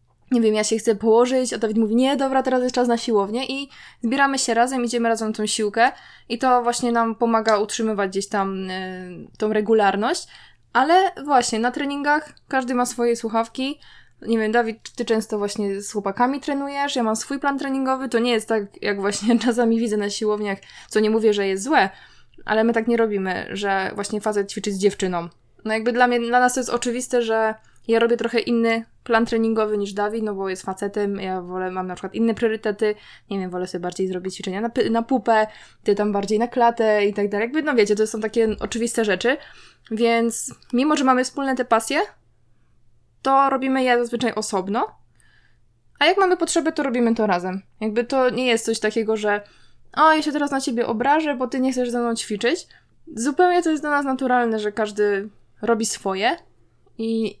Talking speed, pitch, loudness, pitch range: 200 wpm, 230 Hz, -21 LUFS, 210-250 Hz